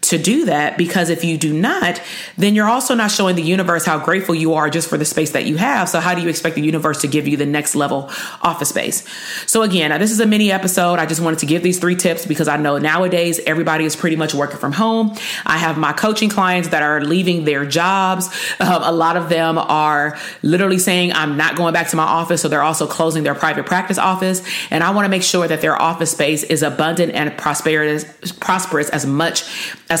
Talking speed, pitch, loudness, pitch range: 240 wpm, 165 Hz, -16 LUFS, 155-185 Hz